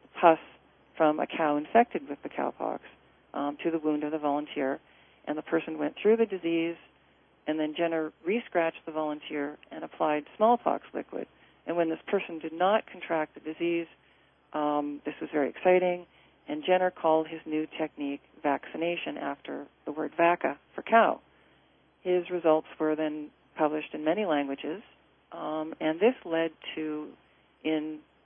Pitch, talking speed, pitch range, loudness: 160 Hz, 155 wpm, 150-170 Hz, -30 LUFS